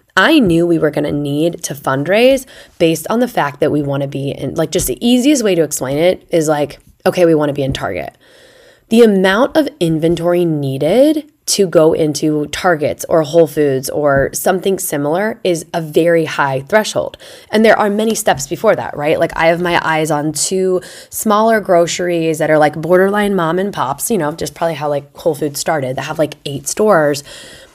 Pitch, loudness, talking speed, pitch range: 165 Hz, -14 LUFS, 195 wpm, 150-195 Hz